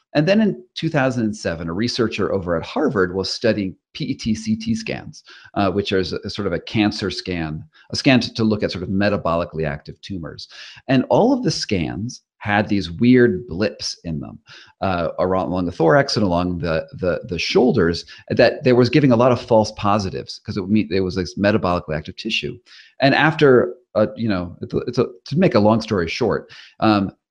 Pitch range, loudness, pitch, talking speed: 90-115 Hz, -19 LUFS, 105 Hz, 200 wpm